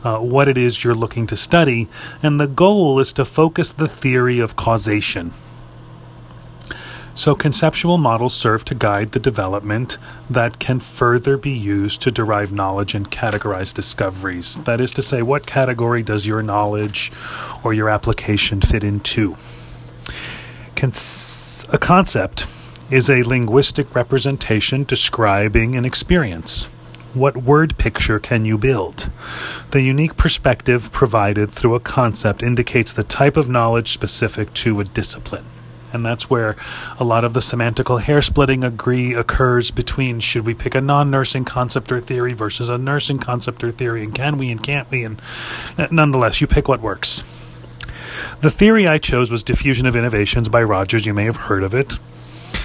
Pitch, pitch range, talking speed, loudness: 120 Hz, 110-135 Hz, 155 wpm, -17 LUFS